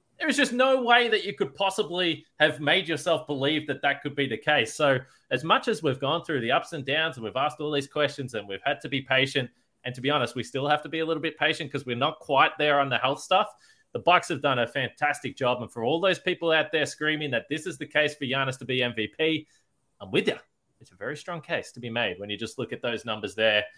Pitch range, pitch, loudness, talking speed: 135-160 Hz, 150 Hz, -26 LUFS, 275 wpm